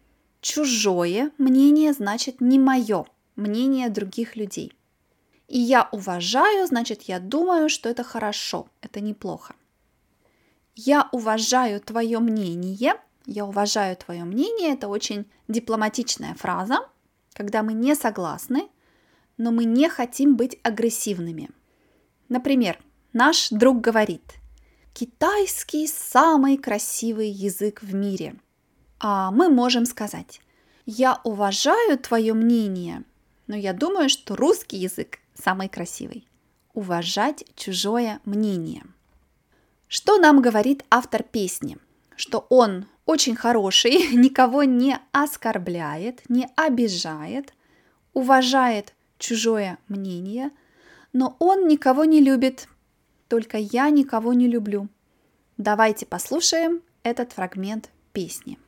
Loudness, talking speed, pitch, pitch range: -22 LUFS, 105 wpm, 235 Hz, 210-270 Hz